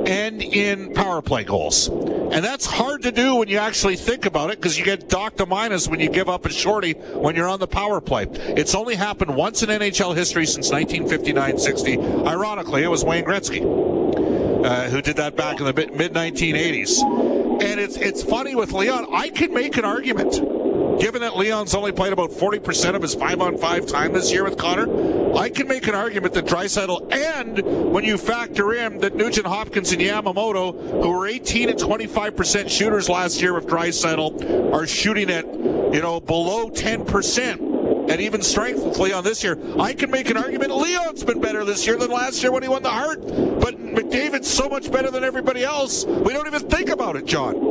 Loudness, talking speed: -20 LUFS, 200 wpm